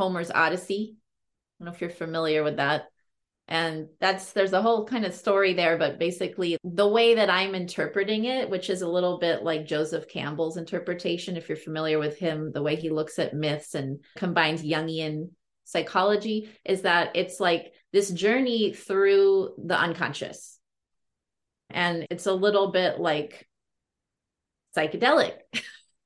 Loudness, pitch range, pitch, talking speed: -26 LUFS, 160-195 Hz, 175 Hz, 155 wpm